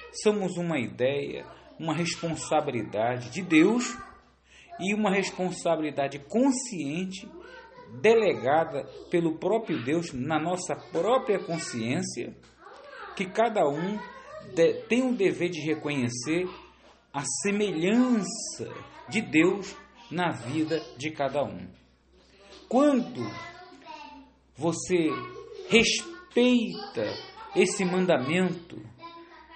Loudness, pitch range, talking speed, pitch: -27 LUFS, 160-245 Hz, 85 wpm, 185 Hz